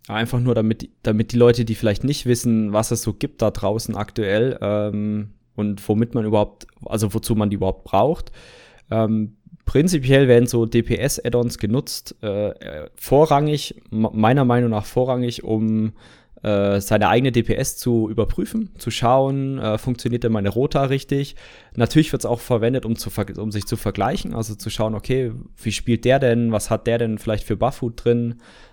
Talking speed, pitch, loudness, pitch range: 180 wpm, 115 Hz, -20 LUFS, 110-125 Hz